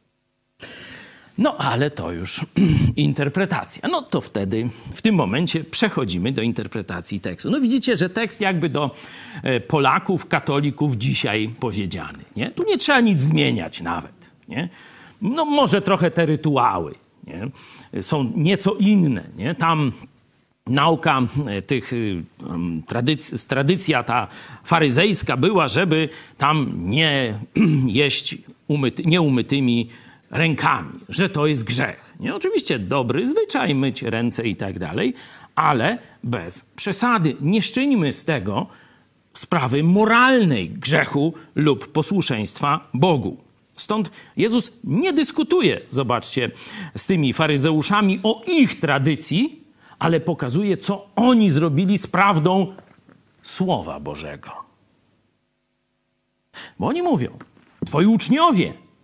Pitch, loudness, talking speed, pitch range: 155 Hz, -20 LUFS, 110 wpm, 130-195 Hz